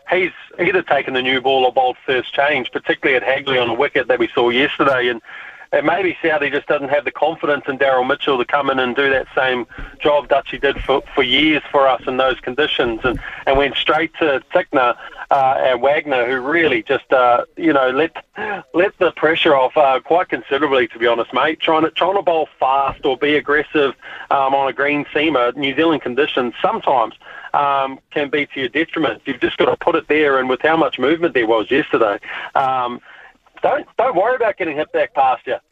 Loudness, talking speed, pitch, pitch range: -17 LUFS, 215 wpm, 140 Hz, 130-150 Hz